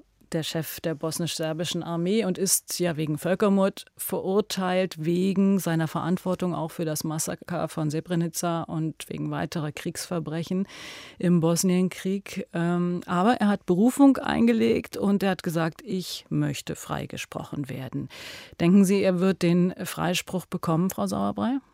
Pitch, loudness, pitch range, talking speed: 175 Hz, -26 LUFS, 165-190 Hz, 130 wpm